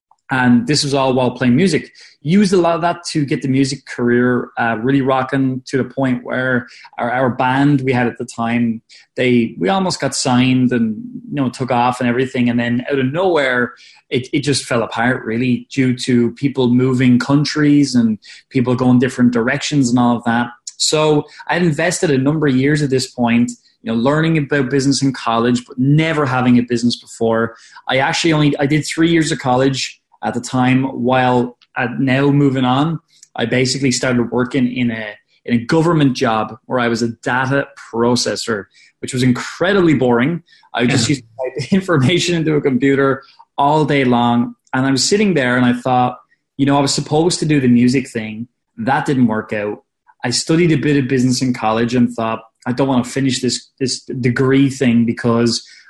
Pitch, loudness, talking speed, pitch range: 130 Hz, -16 LUFS, 195 wpm, 120-145 Hz